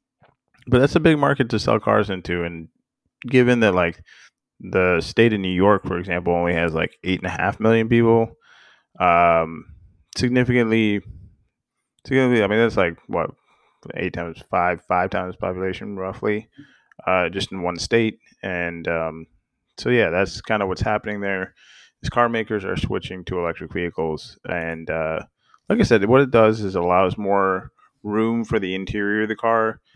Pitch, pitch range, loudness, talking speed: 100 Hz, 90-115 Hz, -21 LUFS, 170 wpm